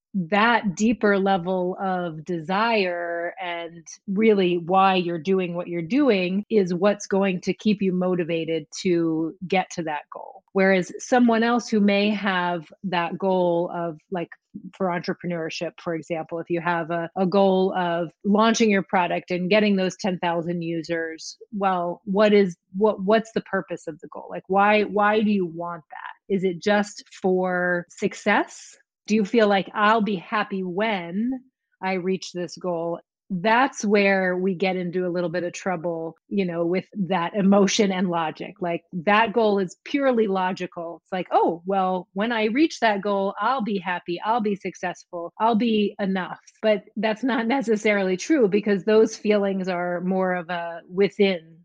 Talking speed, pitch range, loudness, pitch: 165 wpm, 175-210 Hz, -23 LUFS, 190 Hz